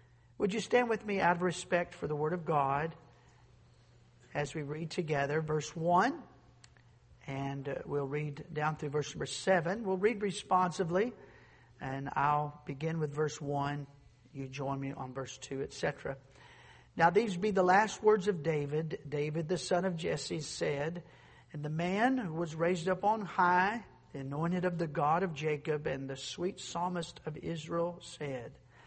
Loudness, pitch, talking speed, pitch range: -34 LUFS, 155 Hz, 165 wpm, 140-180 Hz